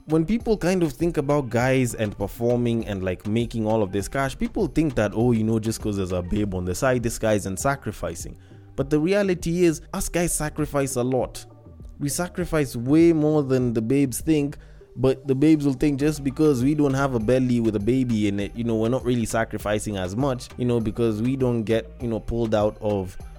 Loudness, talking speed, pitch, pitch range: -23 LUFS, 225 wpm, 120 Hz, 110-145 Hz